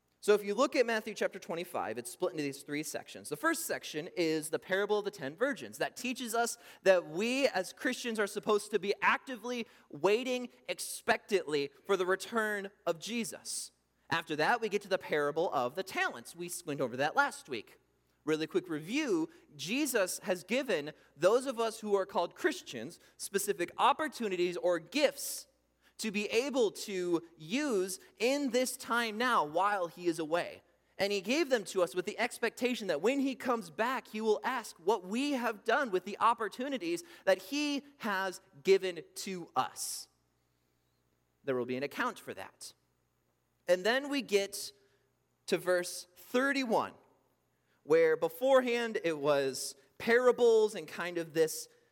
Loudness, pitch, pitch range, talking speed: -33 LUFS, 205 Hz, 175-250 Hz, 165 wpm